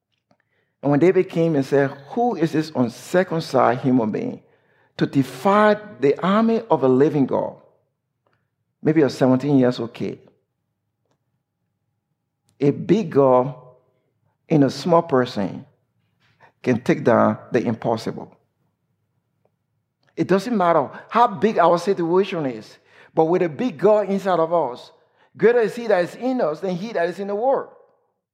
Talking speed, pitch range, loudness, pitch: 150 wpm, 130-195 Hz, -20 LUFS, 155 Hz